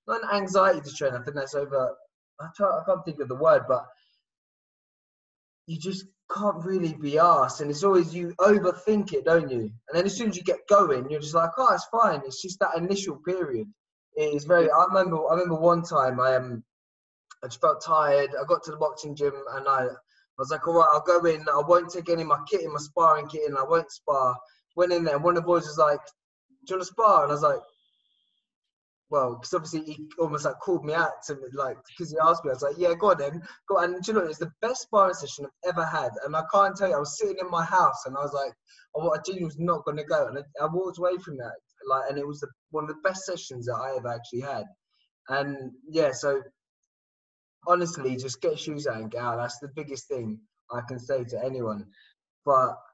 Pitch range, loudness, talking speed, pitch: 140-185 Hz, -26 LUFS, 245 wpm, 165 Hz